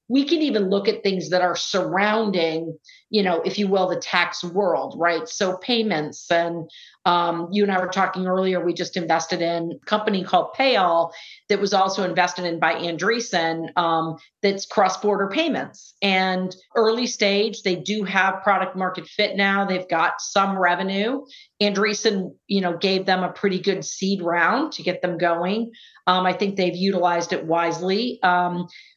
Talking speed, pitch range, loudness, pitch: 170 wpm, 175-205 Hz, -22 LUFS, 185 Hz